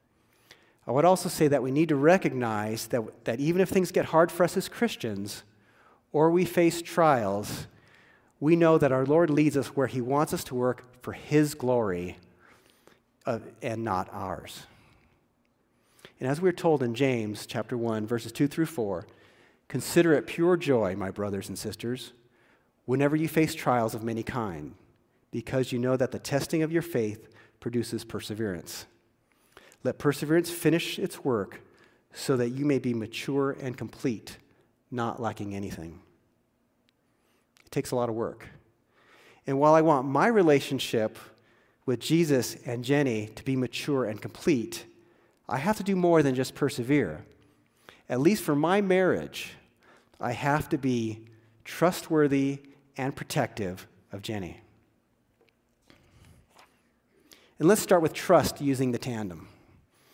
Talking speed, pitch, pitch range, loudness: 150 wpm, 130 Hz, 115-150 Hz, -27 LUFS